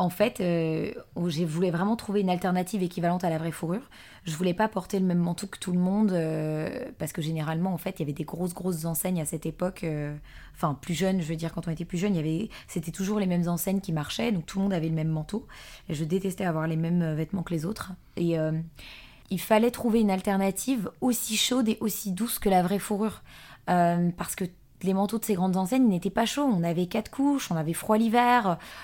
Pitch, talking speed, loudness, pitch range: 180 Hz, 245 wpm, -28 LUFS, 165-205 Hz